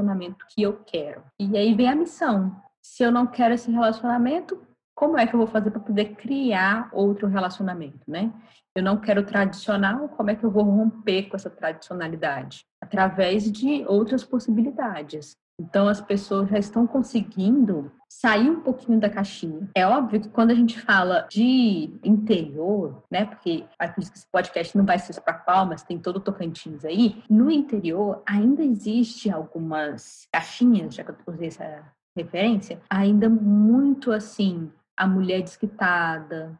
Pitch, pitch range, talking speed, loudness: 205 Hz, 185-230 Hz, 165 wpm, -23 LUFS